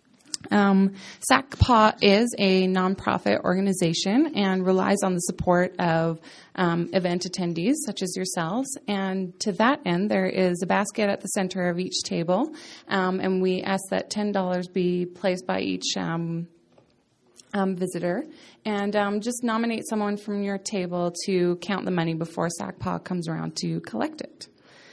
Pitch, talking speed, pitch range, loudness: 190 Hz, 155 wpm, 180-205 Hz, -25 LUFS